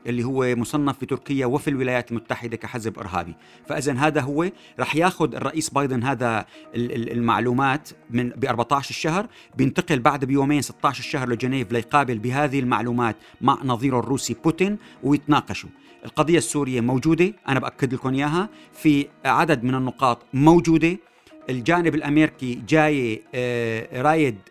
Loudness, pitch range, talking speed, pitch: -22 LUFS, 120-150 Hz, 125 wpm, 135 Hz